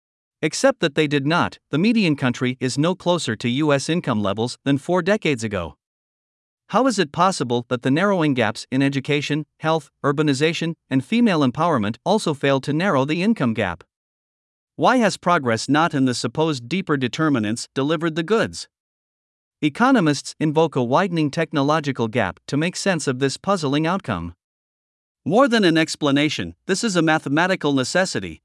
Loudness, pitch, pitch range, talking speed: -20 LUFS, 150 Hz, 130-175 Hz, 160 wpm